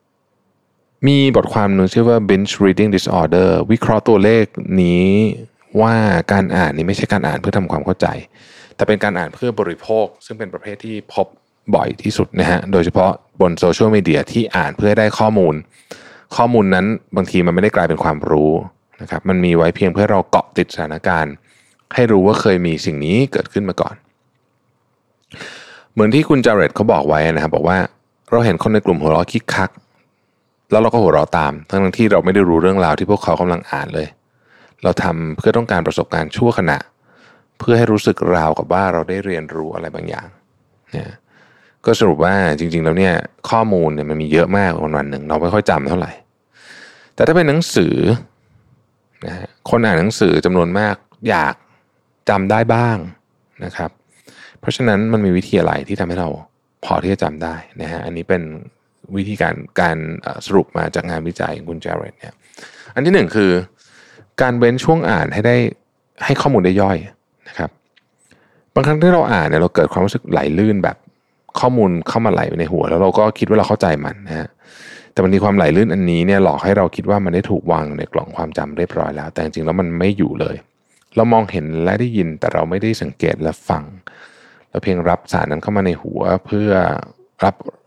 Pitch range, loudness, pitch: 85-105 Hz, -16 LUFS, 95 Hz